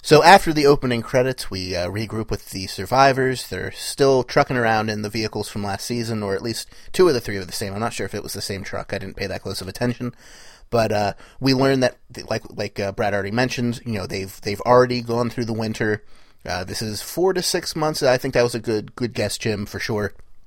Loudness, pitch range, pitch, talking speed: -21 LUFS, 100-125 Hz, 110 Hz, 250 wpm